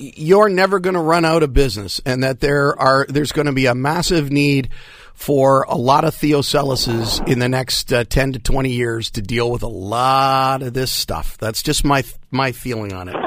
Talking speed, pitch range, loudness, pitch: 215 wpm, 120-145 Hz, -17 LUFS, 135 Hz